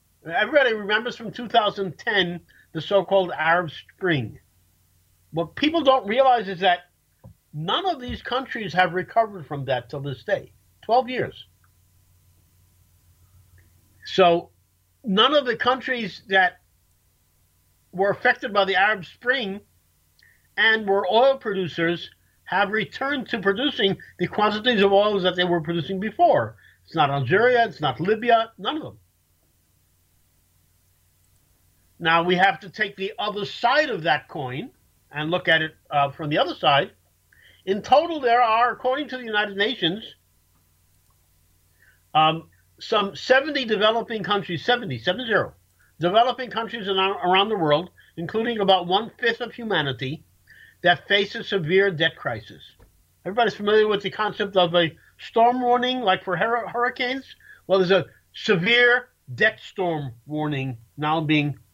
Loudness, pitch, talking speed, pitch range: -22 LUFS, 185 Hz, 140 wpm, 130-220 Hz